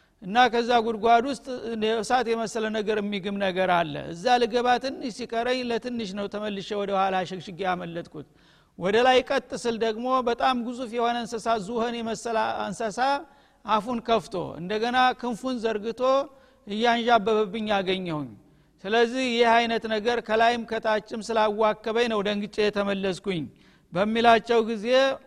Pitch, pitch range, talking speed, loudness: 230 Hz, 205-240 Hz, 125 wpm, -25 LUFS